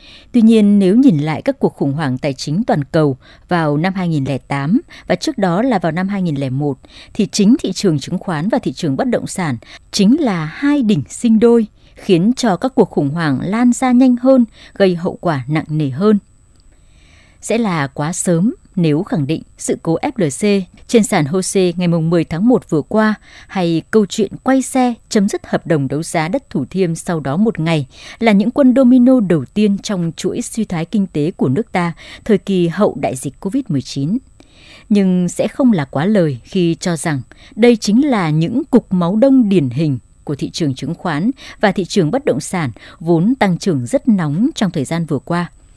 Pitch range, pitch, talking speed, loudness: 155-225 Hz, 185 Hz, 200 wpm, -15 LUFS